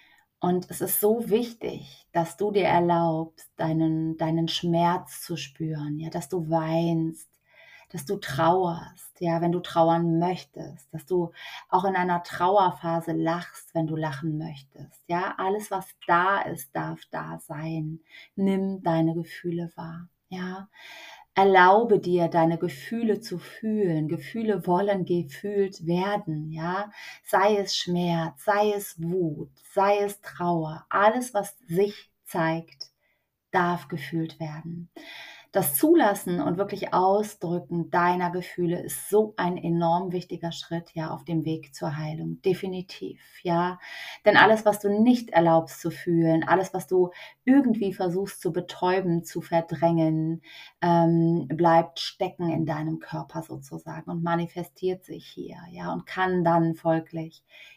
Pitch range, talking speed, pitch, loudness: 165-190 Hz, 135 wpm, 175 Hz, -26 LUFS